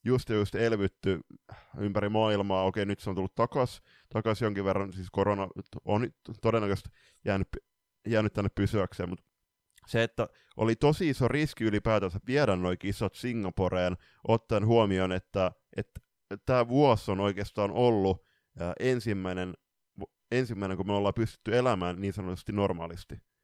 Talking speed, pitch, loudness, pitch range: 140 wpm, 100 Hz, -30 LUFS, 95-115 Hz